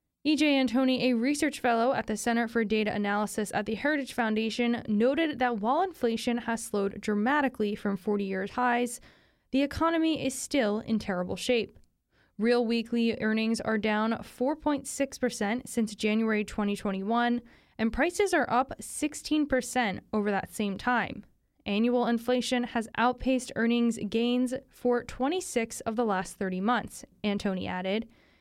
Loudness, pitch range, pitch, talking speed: -29 LUFS, 215-255 Hz, 235 Hz, 140 wpm